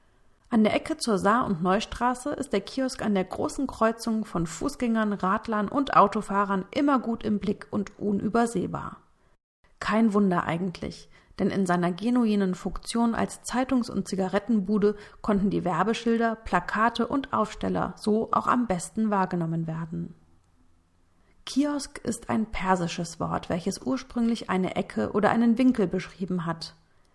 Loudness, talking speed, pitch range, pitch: -27 LUFS, 140 wpm, 185-230 Hz, 205 Hz